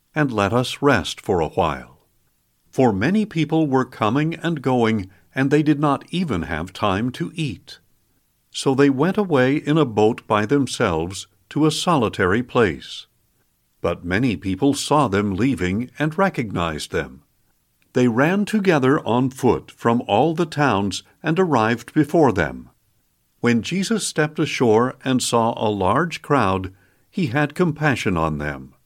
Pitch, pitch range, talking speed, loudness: 130 Hz, 100-155 Hz, 150 wpm, -20 LUFS